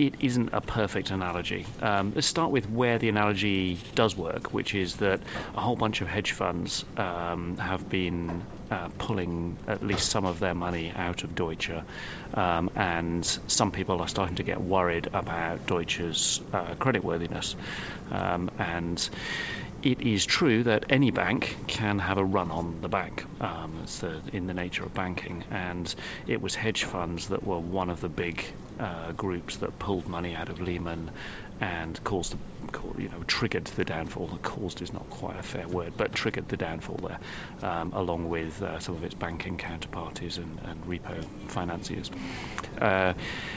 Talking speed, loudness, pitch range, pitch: 175 wpm, -30 LUFS, 85-105 Hz, 90 Hz